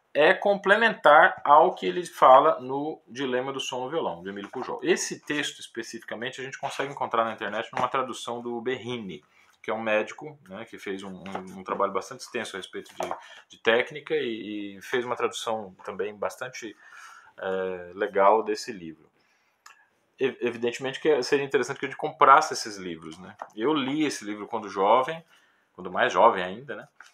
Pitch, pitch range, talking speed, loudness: 130 Hz, 105-175 Hz, 175 wpm, -25 LUFS